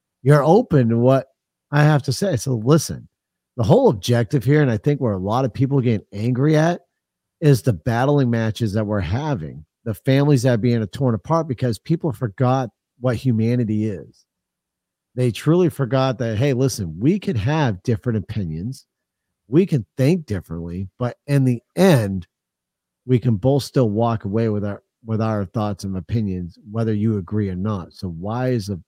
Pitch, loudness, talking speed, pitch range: 120 Hz, -20 LUFS, 180 wpm, 105-140 Hz